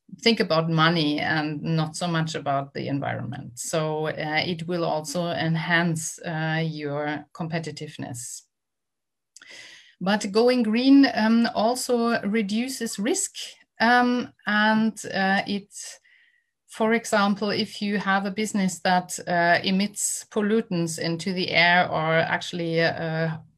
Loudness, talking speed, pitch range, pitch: -24 LUFS, 120 wpm, 160-220 Hz, 180 Hz